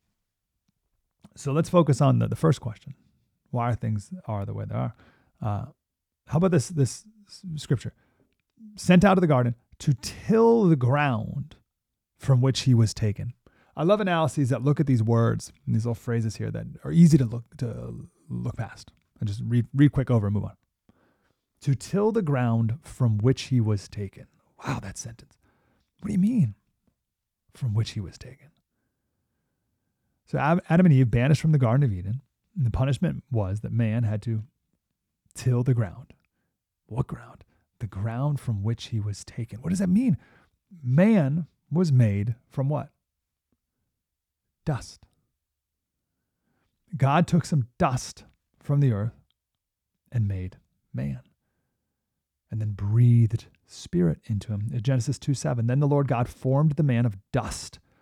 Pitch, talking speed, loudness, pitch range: 125 Hz, 160 wpm, -25 LUFS, 110-150 Hz